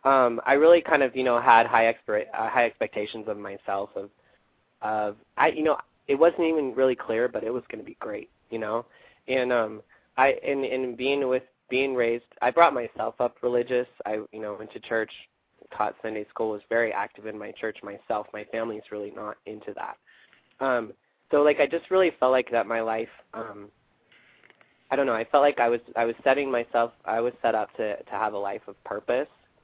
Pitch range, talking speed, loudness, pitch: 115-135 Hz, 210 wpm, -26 LUFS, 120 Hz